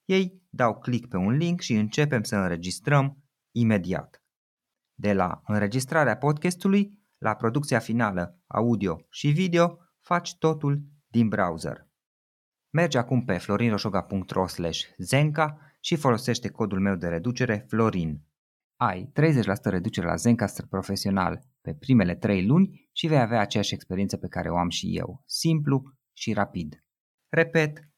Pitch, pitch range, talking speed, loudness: 120 Hz, 100-150 Hz, 135 wpm, -26 LUFS